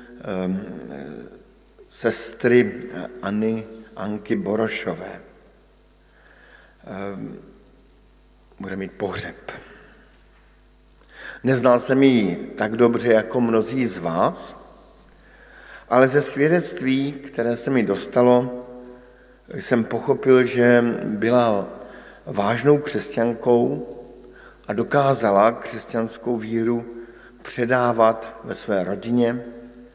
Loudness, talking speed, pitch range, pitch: -21 LUFS, 75 wpm, 110-125 Hz, 120 Hz